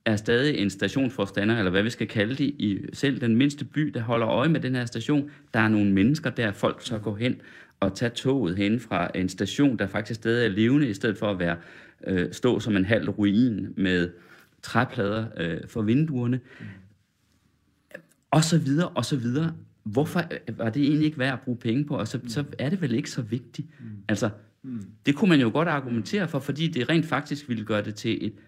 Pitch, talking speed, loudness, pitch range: 120 Hz, 210 wpm, -26 LUFS, 105-140 Hz